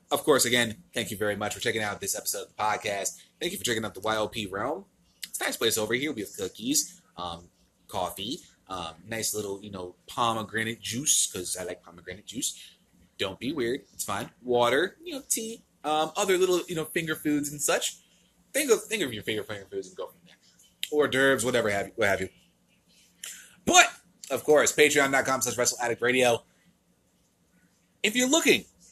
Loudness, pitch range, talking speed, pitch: -27 LUFS, 110-180 Hz, 185 wpm, 130 Hz